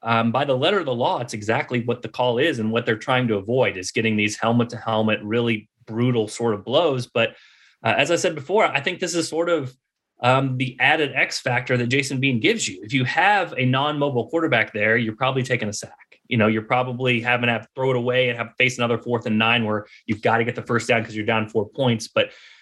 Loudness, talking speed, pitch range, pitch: -21 LUFS, 255 wpm, 115-130 Hz, 120 Hz